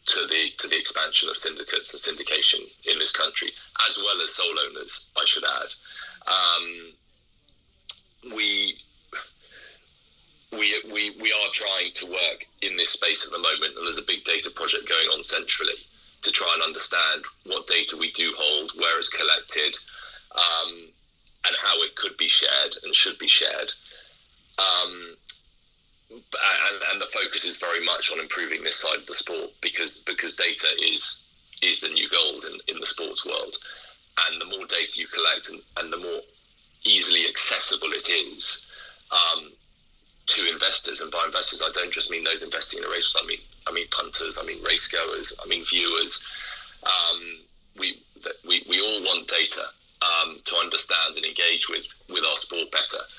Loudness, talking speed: -22 LUFS, 170 wpm